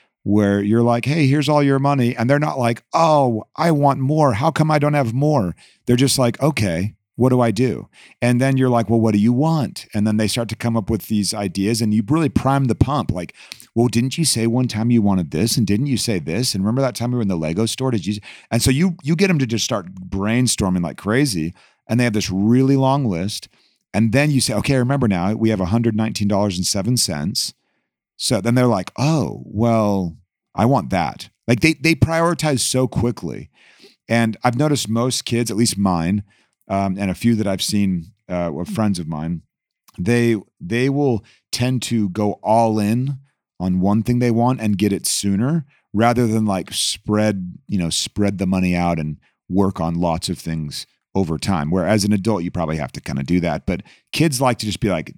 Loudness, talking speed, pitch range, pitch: -19 LUFS, 215 wpm, 100-130 Hz, 115 Hz